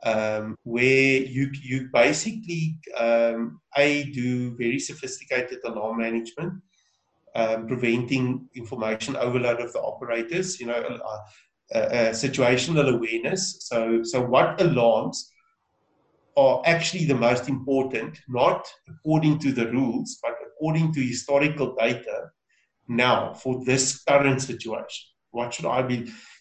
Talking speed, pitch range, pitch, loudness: 125 wpm, 120-150 Hz, 130 Hz, -24 LUFS